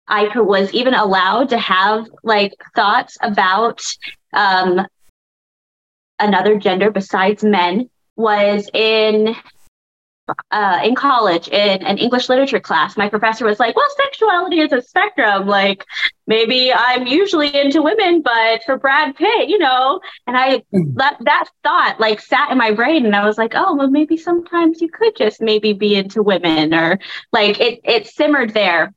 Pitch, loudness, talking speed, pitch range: 220 Hz, -15 LUFS, 160 wpm, 200-275 Hz